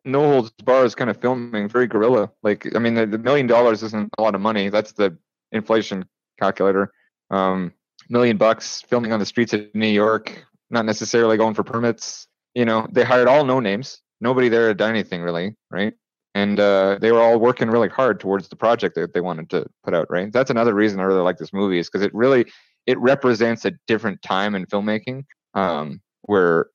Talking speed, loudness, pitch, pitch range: 210 wpm, -20 LUFS, 110 Hz, 100-120 Hz